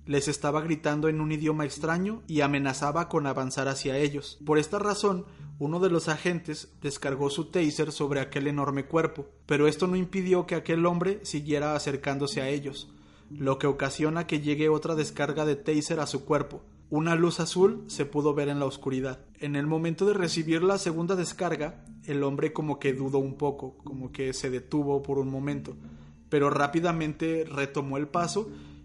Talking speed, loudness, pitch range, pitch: 180 wpm, -28 LUFS, 140-165 Hz, 150 Hz